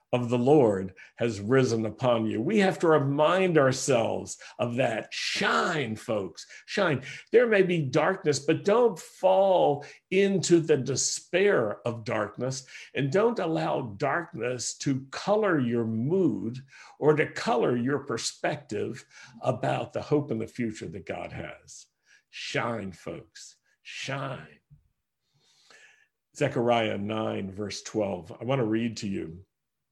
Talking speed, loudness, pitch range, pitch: 130 wpm, -27 LUFS, 115-180 Hz, 135 Hz